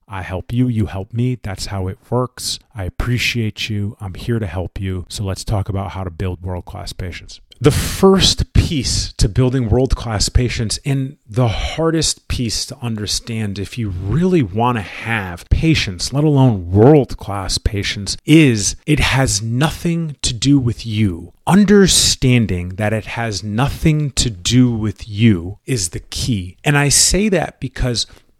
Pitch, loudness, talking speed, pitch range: 110 Hz, -17 LUFS, 165 wpm, 95-130 Hz